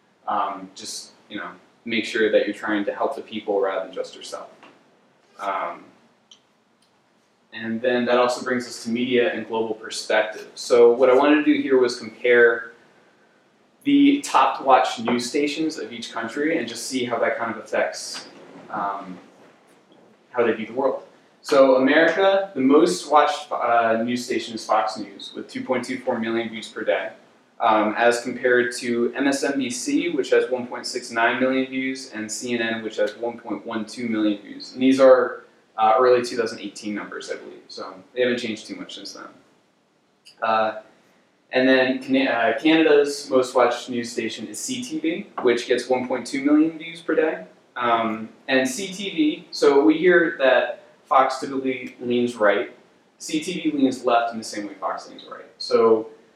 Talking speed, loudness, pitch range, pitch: 160 wpm, -21 LUFS, 115-150 Hz, 125 Hz